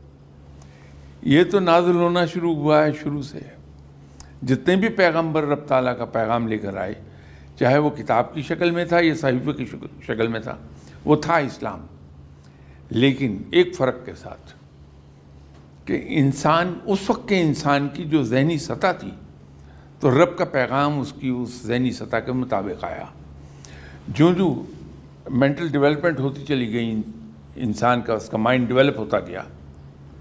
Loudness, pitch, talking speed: -21 LUFS, 125 Hz, 155 wpm